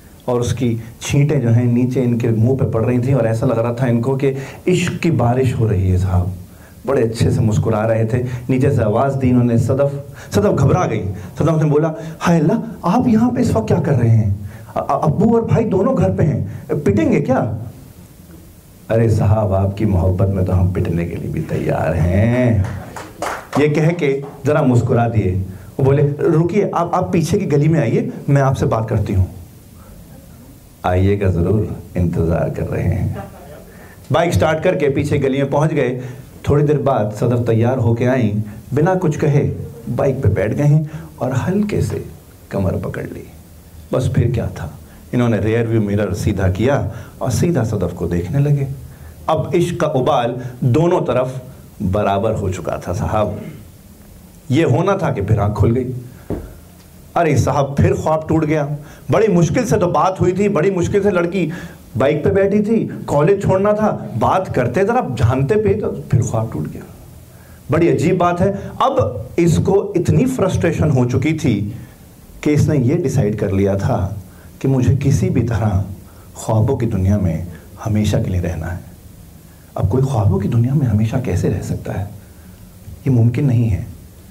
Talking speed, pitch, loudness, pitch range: 175 wpm, 120 Hz, -17 LUFS, 100-145 Hz